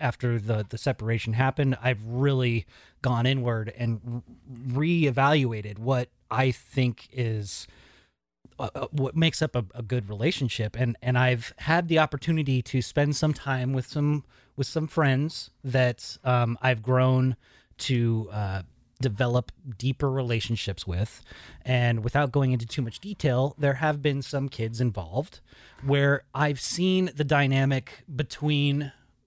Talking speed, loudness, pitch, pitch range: 135 wpm, -27 LUFS, 130 Hz, 120-140 Hz